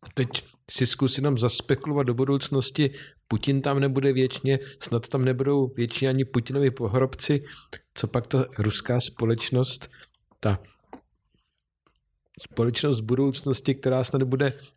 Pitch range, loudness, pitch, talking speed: 125-140 Hz, -25 LUFS, 135 Hz, 125 wpm